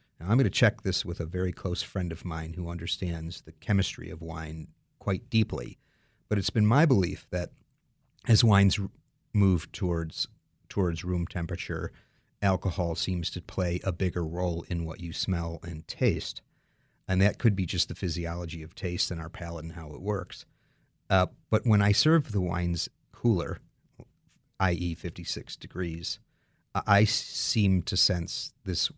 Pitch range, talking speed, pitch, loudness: 85-105 Hz, 165 wpm, 95 Hz, -29 LUFS